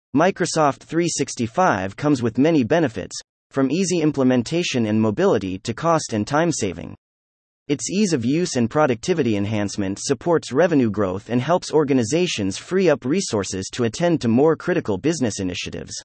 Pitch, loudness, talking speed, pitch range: 130 Hz, -20 LUFS, 145 wpm, 105-160 Hz